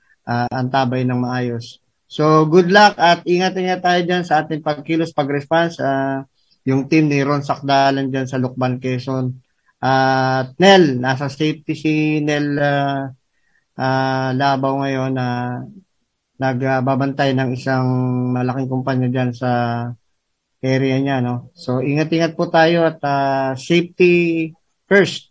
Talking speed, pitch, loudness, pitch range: 140 wpm, 135 Hz, -17 LUFS, 130-155 Hz